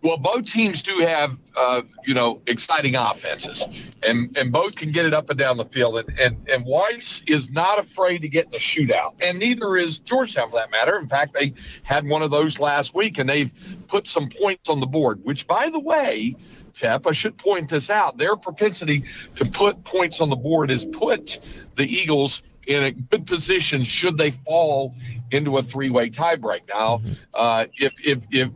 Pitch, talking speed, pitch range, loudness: 150 Hz, 200 wpm, 135-185 Hz, -21 LUFS